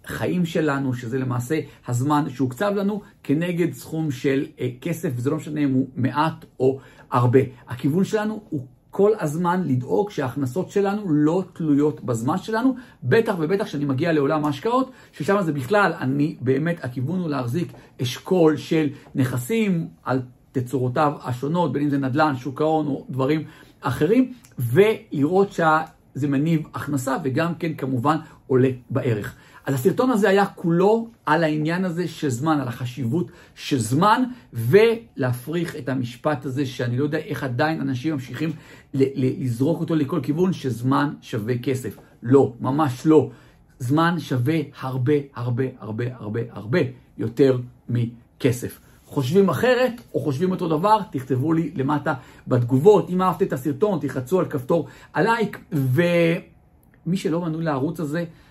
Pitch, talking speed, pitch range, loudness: 150 Hz, 140 wpm, 130-170 Hz, -22 LUFS